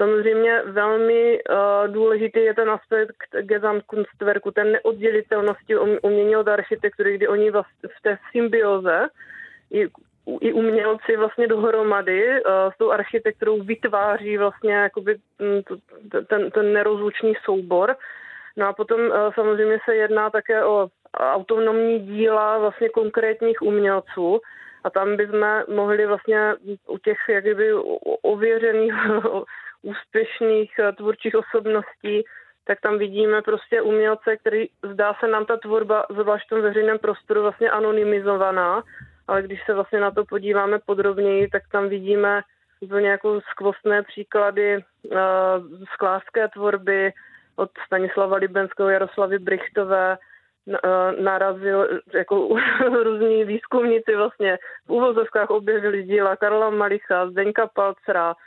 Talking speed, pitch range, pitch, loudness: 120 wpm, 200-225 Hz, 210 Hz, -21 LUFS